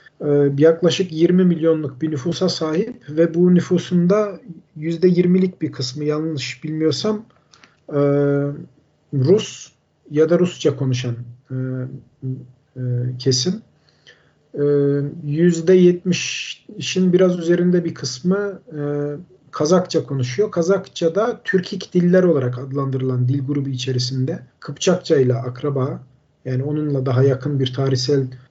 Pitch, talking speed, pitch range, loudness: 150 Hz, 95 wpm, 135-180 Hz, -19 LUFS